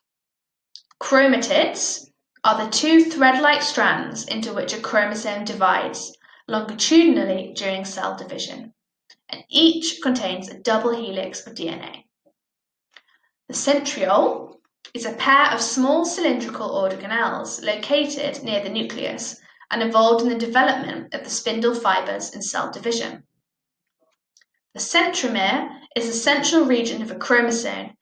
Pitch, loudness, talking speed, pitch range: 240 Hz, -20 LUFS, 120 wpm, 220-285 Hz